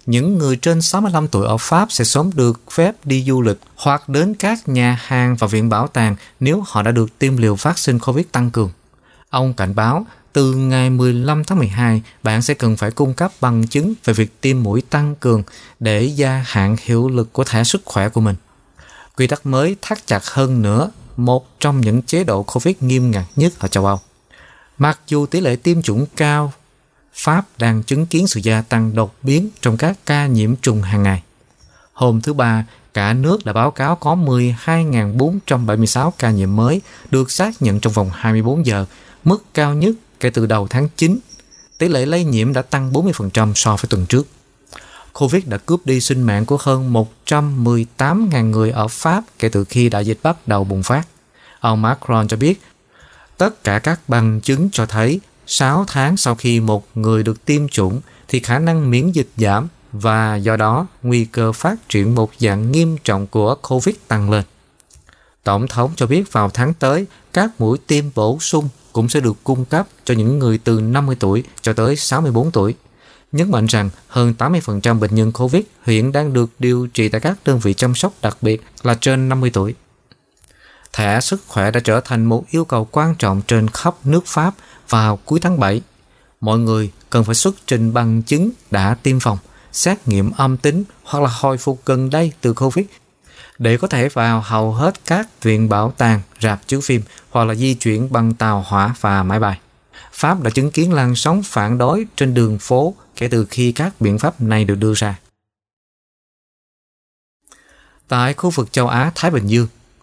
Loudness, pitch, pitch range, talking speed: -16 LUFS, 125 Hz, 110-150 Hz, 195 wpm